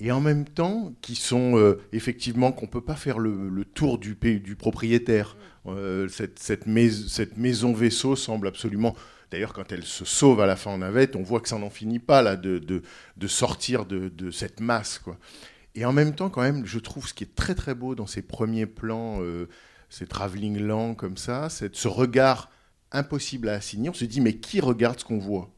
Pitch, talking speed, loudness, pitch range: 115 Hz, 220 wpm, -26 LUFS, 100-125 Hz